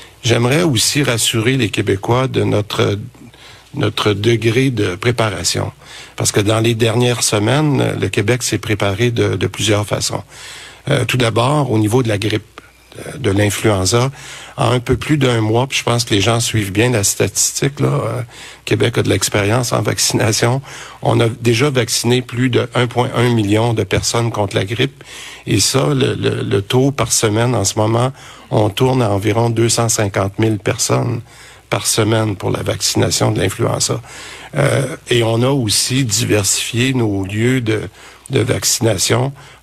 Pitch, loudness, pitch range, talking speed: 115 Hz, -15 LUFS, 110-125 Hz, 165 wpm